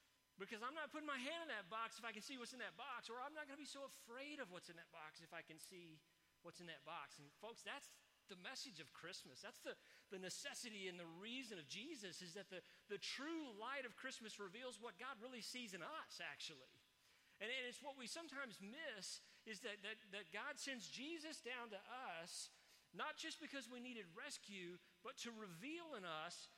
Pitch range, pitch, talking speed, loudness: 195-270 Hz, 235 Hz, 220 wpm, -53 LUFS